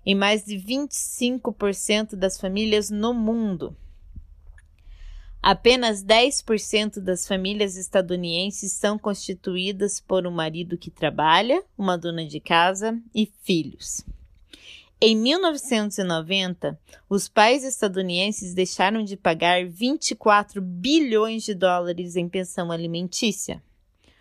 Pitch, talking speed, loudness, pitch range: 195 Hz, 100 wpm, -23 LUFS, 175-215 Hz